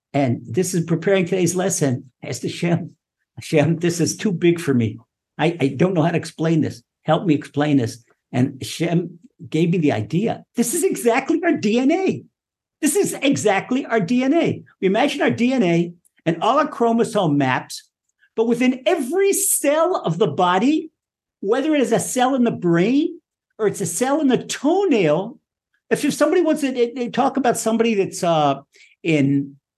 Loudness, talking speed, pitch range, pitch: -20 LUFS, 175 wpm, 155-260 Hz, 190 Hz